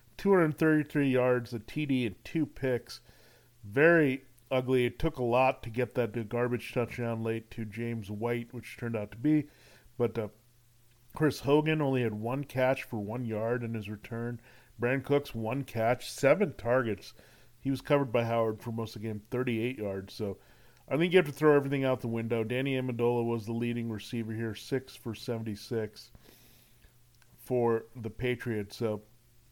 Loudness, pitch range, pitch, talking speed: -31 LUFS, 115-130 Hz, 120 Hz, 170 wpm